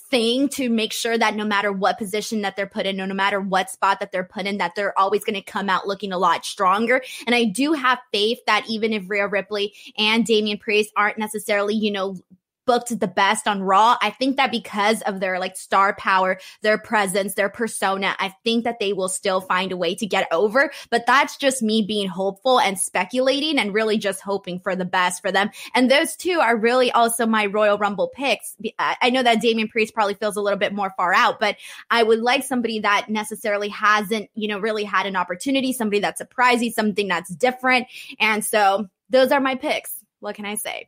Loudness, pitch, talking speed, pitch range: -21 LUFS, 210 Hz, 220 wpm, 195-230 Hz